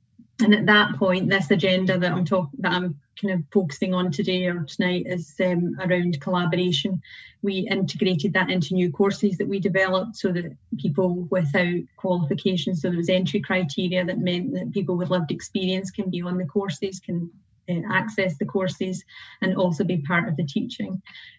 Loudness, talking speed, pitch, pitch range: -24 LUFS, 180 wpm, 185 Hz, 180-195 Hz